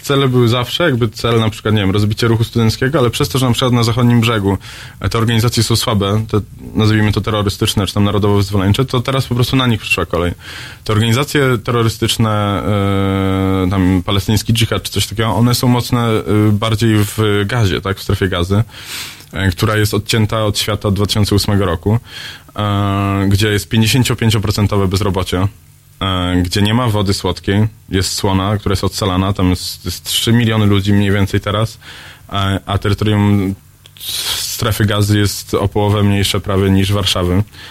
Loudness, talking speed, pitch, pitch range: -15 LUFS, 165 wpm, 105 Hz, 100-115 Hz